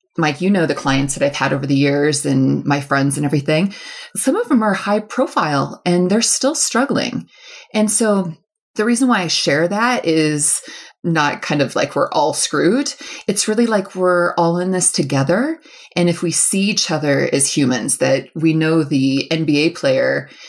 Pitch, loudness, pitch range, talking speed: 175 Hz, -16 LUFS, 150-215 Hz, 185 wpm